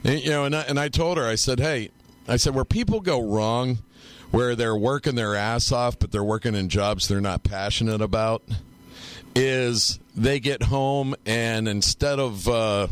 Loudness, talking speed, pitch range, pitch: -23 LUFS, 190 wpm, 105-130 Hz, 115 Hz